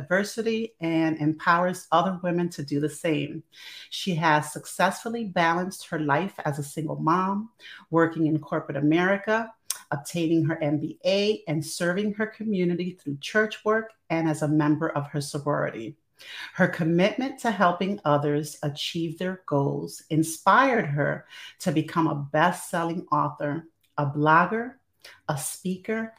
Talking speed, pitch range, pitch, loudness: 135 wpm, 150-190 Hz, 165 Hz, -26 LUFS